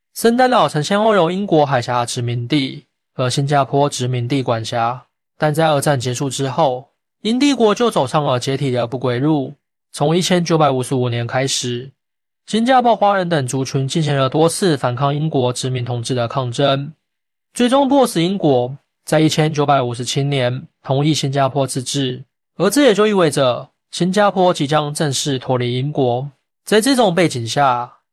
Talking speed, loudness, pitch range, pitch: 265 characters per minute, -17 LUFS, 130-165 Hz, 140 Hz